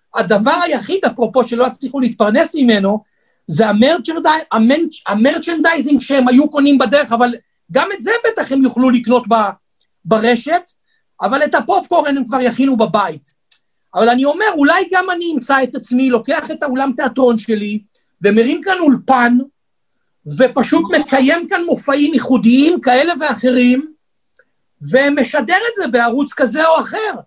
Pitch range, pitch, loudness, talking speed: 245-315 Hz, 270 Hz, -14 LUFS, 135 wpm